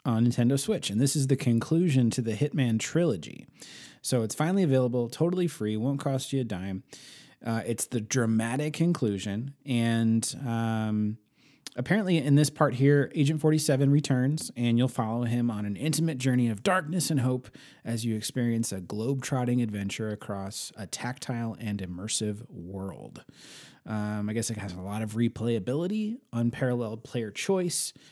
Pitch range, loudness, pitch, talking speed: 110-145 Hz, -28 LUFS, 120 Hz, 160 wpm